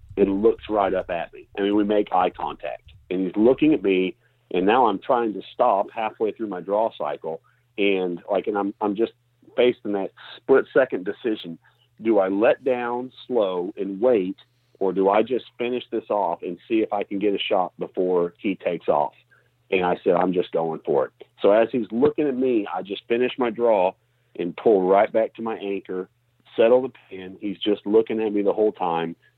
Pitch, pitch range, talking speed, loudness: 105 Hz, 95-120 Hz, 210 wpm, -23 LUFS